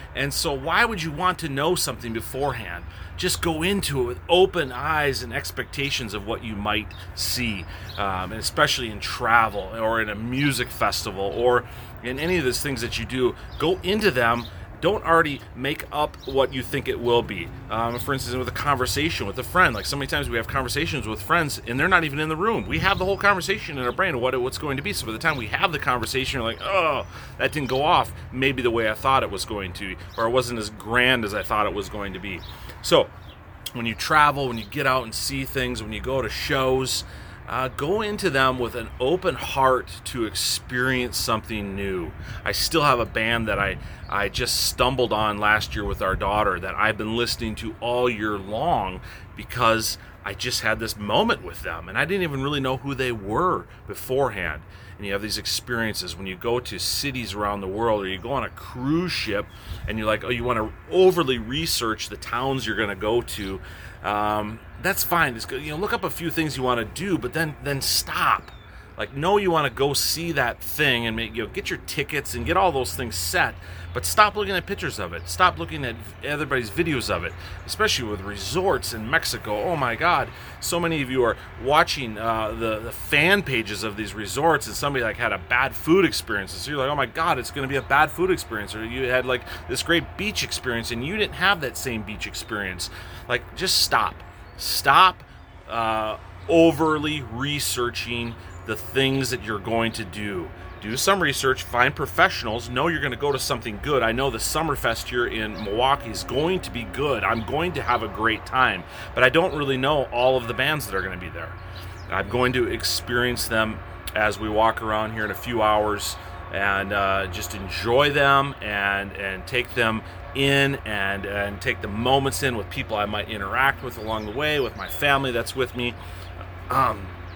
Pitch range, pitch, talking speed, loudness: 100-135 Hz, 115 Hz, 220 wpm, -23 LUFS